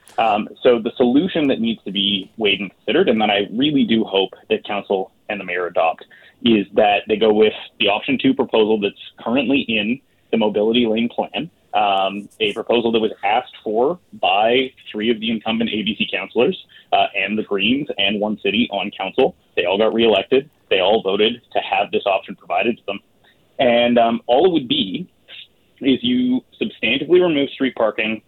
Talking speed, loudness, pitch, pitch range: 185 wpm, -18 LUFS, 115 Hz, 105-135 Hz